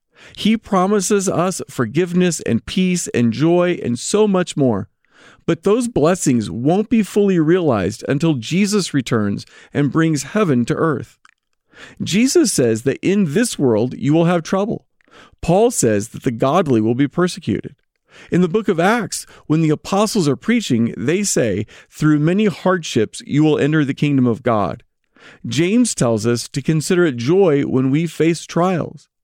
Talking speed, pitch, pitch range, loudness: 160 wpm, 160 Hz, 130-190 Hz, -17 LUFS